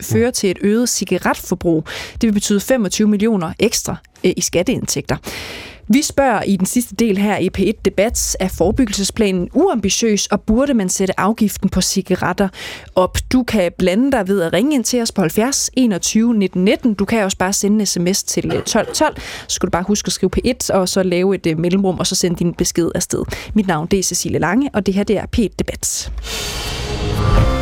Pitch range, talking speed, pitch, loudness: 185-225 Hz, 195 wpm, 195 Hz, -17 LUFS